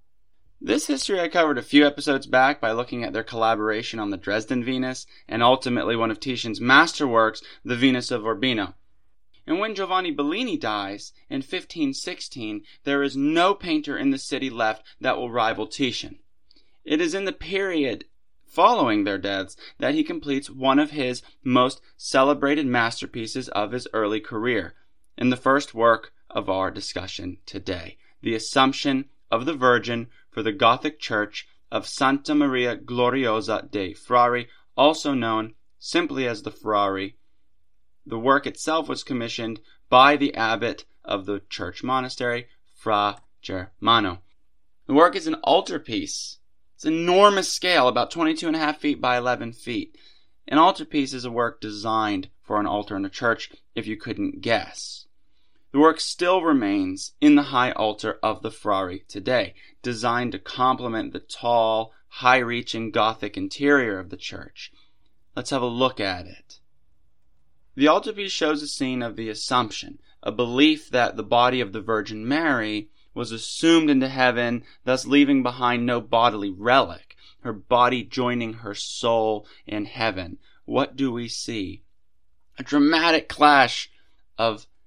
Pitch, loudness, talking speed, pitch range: 125 Hz, -23 LUFS, 150 wpm, 110-145 Hz